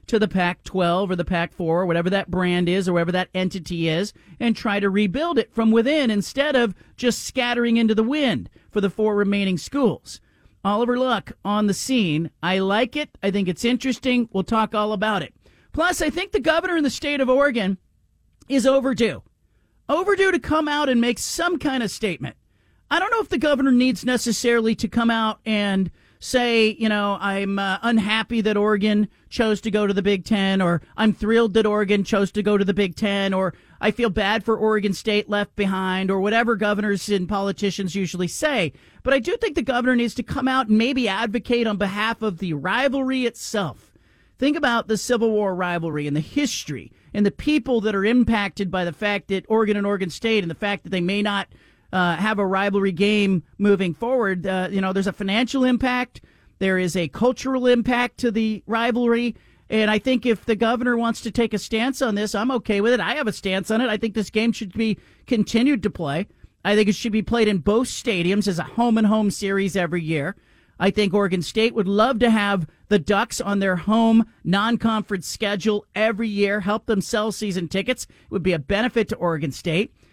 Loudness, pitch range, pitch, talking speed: -21 LUFS, 195-235 Hz, 215 Hz, 210 wpm